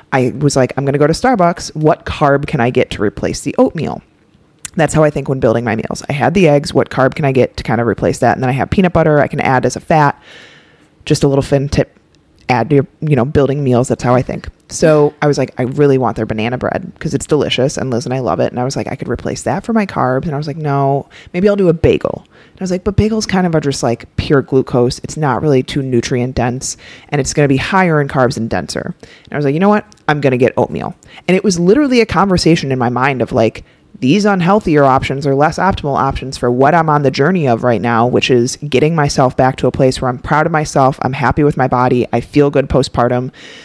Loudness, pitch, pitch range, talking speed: -14 LUFS, 140 Hz, 125-155 Hz, 270 wpm